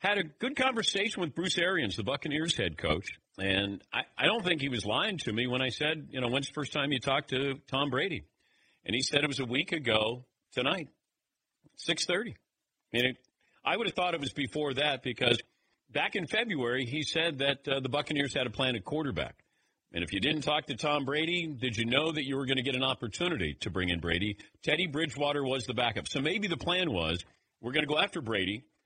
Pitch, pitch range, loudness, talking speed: 140 Hz, 120-155 Hz, -31 LUFS, 225 wpm